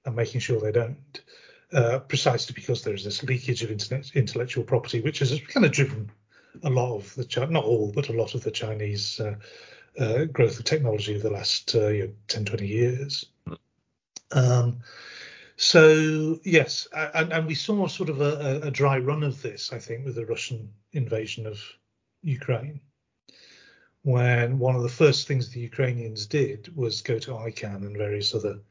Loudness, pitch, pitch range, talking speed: -25 LUFS, 125 Hz, 110-145 Hz, 180 wpm